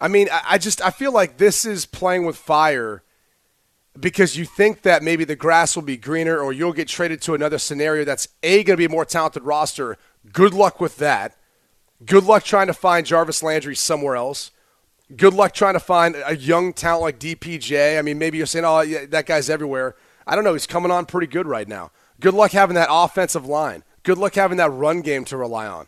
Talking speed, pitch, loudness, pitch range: 225 wpm, 165 Hz, -18 LUFS, 155-185 Hz